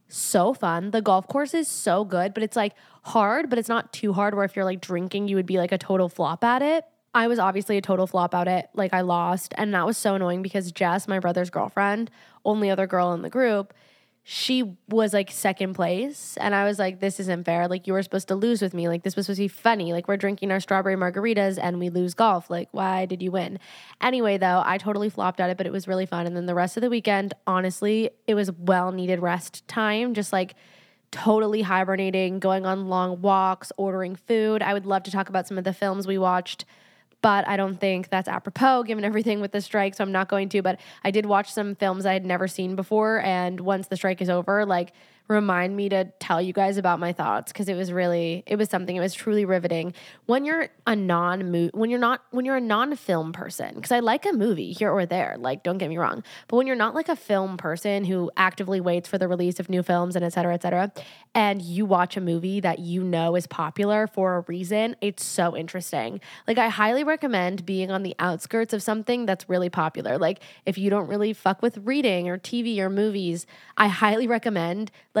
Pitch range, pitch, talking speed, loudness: 180-210 Hz, 195 Hz, 235 wpm, -24 LUFS